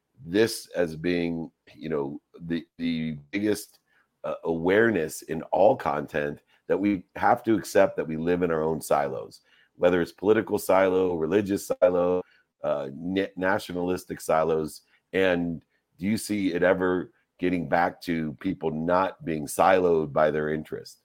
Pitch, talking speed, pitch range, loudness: 90 Hz, 145 wpm, 80-95 Hz, -26 LUFS